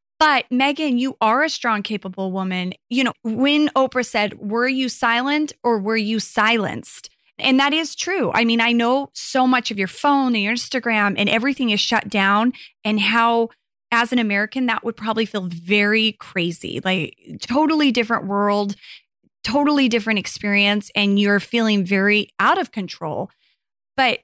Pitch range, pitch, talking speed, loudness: 205-255 Hz, 225 Hz, 165 wpm, -19 LUFS